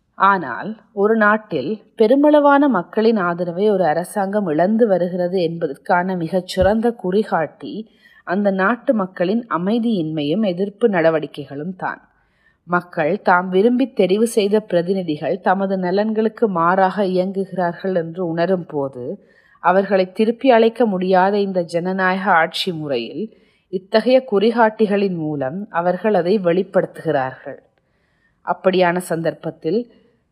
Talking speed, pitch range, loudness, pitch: 95 wpm, 175-215 Hz, -18 LUFS, 190 Hz